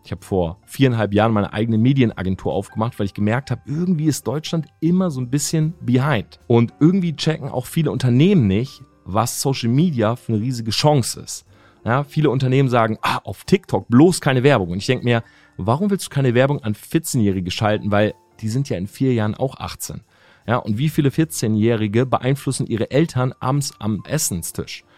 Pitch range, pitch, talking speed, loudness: 105-145 Hz, 125 Hz, 185 wpm, -19 LUFS